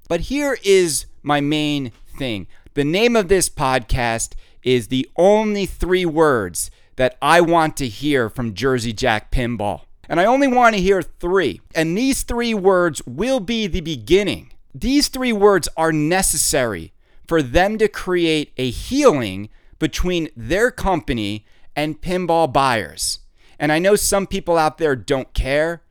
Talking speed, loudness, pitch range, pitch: 155 wpm, -18 LUFS, 125-190 Hz, 155 Hz